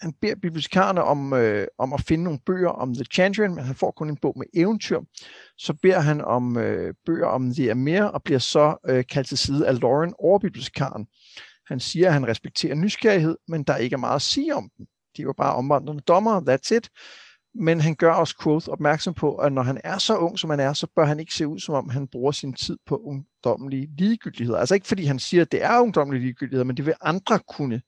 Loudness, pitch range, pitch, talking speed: -23 LUFS, 135-180 Hz, 155 Hz, 235 wpm